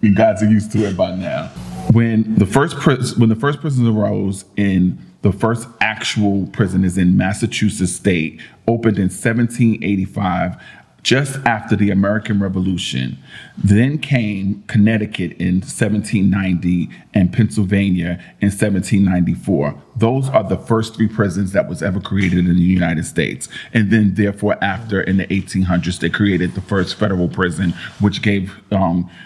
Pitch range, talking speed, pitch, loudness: 95-110 Hz, 150 wpm, 100 Hz, -17 LUFS